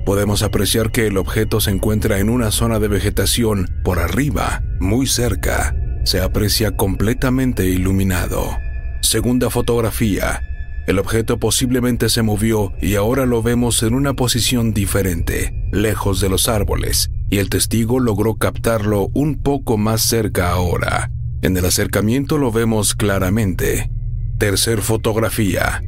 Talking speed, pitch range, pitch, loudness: 130 wpm, 95-115 Hz, 105 Hz, -17 LUFS